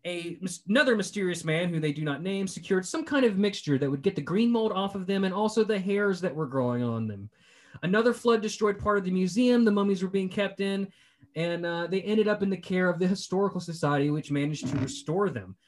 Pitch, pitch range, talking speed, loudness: 190 Hz, 160-205 Hz, 235 wpm, -27 LUFS